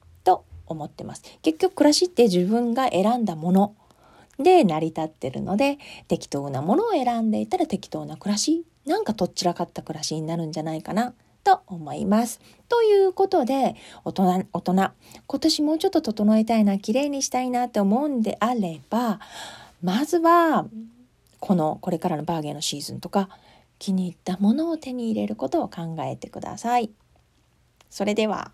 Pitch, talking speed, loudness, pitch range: 215 Hz, 340 characters per minute, -23 LUFS, 175-270 Hz